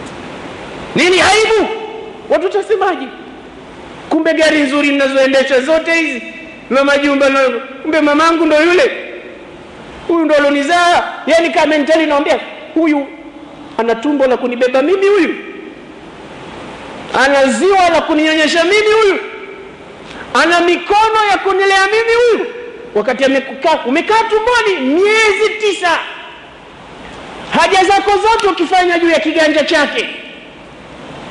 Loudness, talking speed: -12 LUFS, 105 wpm